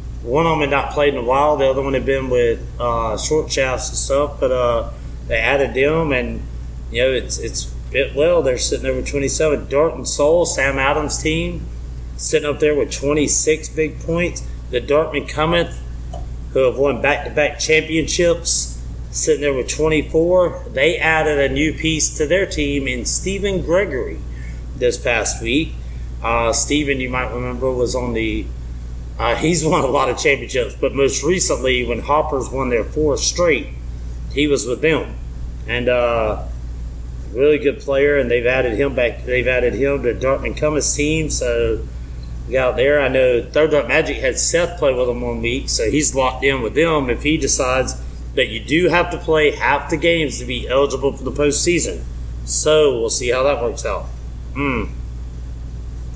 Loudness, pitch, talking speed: -18 LUFS, 130 Hz, 185 wpm